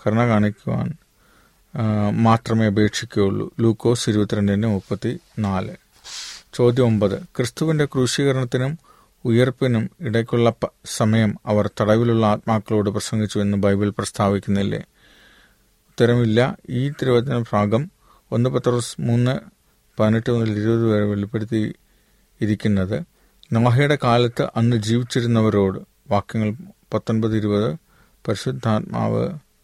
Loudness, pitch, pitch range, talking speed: -20 LUFS, 115 Hz, 105-120 Hz, 85 wpm